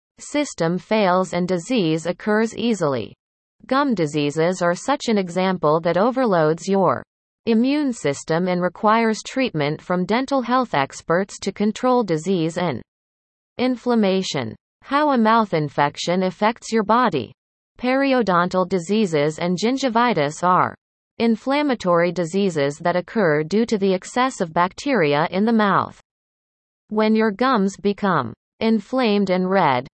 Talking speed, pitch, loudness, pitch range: 120 wpm, 195 Hz, -20 LUFS, 170-230 Hz